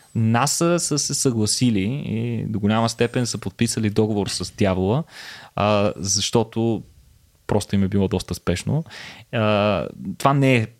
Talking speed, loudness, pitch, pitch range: 140 wpm, -21 LUFS, 110 Hz, 100-120 Hz